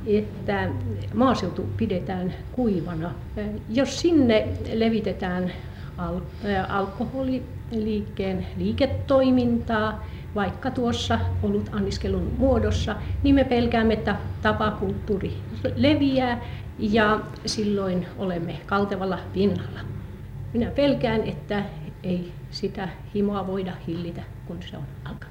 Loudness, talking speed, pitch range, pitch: -25 LUFS, 90 wpm, 160-225 Hz, 195 Hz